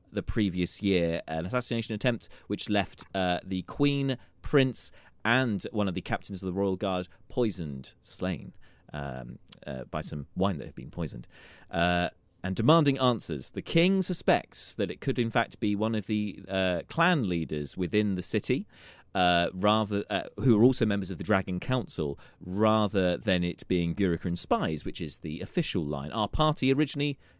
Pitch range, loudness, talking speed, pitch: 90-115 Hz, -29 LUFS, 175 wpm, 100 Hz